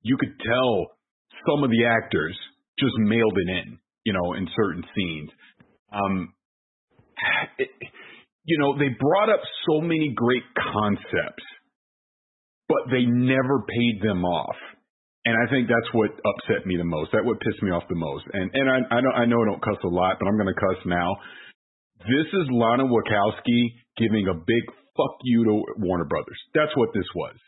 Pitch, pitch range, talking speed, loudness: 115 Hz, 100-125 Hz, 175 wpm, -24 LUFS